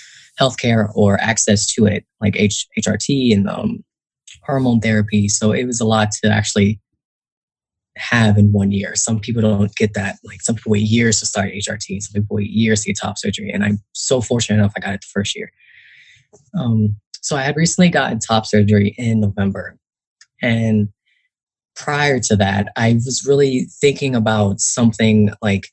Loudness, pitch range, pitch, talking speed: -17 LUFS, 105-115 Hz, 110 Hz, 175 wpm